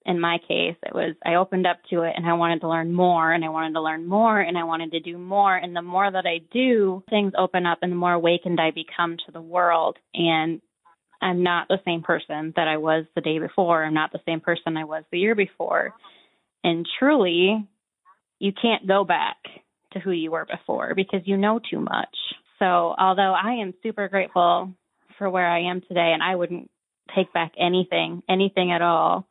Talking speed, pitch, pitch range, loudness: 215 wpm, 175 Hz, 170-195 Hz, -23 LUFS